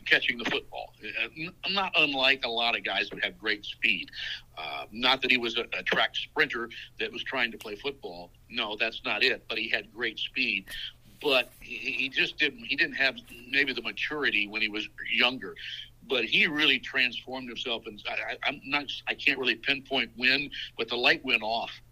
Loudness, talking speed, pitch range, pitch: -27 LUFS, 190 wpm, 115-135 Hz, 125 Hz